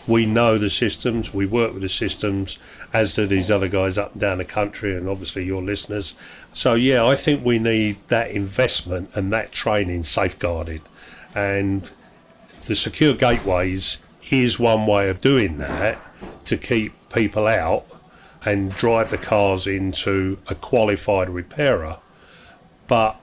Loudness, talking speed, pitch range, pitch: -21 LUFS, 150 wpm, 95-115 Hz, 100 Hz